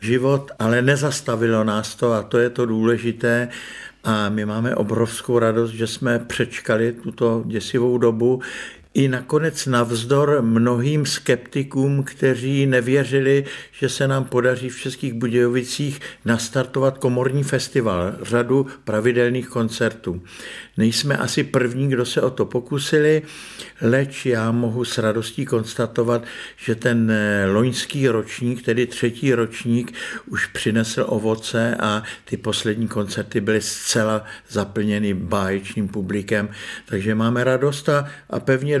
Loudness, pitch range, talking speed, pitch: -21 LUFS, 110-130 Hz, 120 wpm, 120 Hz